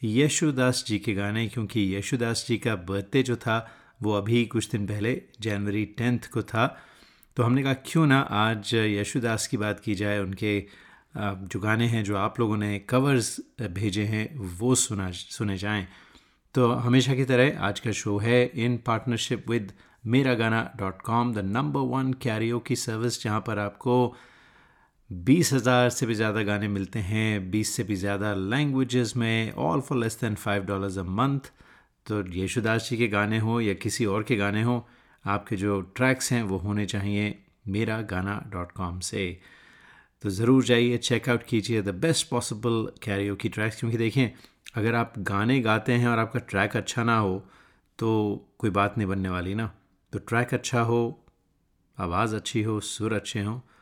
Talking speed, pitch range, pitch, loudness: 175 wpm, 105-120 Hz, 110 Hz, -26 LUFS